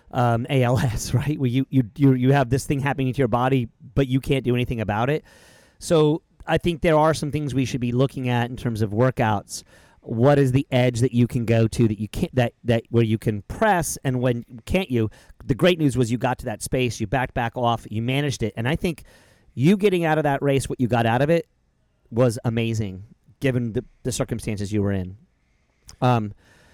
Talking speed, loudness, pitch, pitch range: 225 wpm, -22 LUFS, 125 Hz, 115-140 Hz